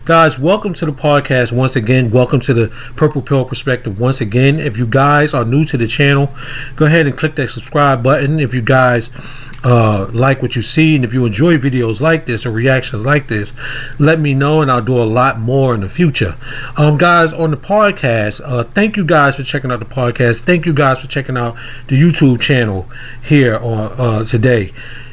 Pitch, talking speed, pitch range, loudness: 130 Hz, 210 wpm, 120-150 Hz, -13 LUFS